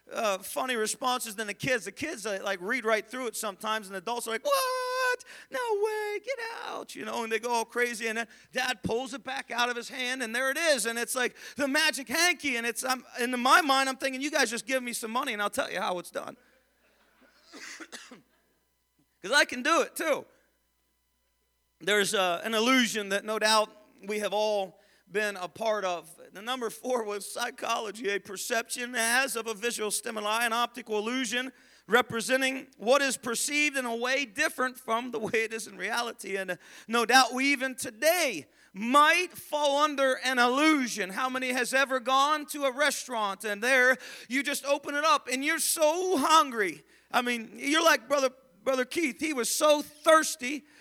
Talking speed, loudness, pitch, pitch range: 195 wpm, -28 LUFS, 250 Hz, 220-280 Hz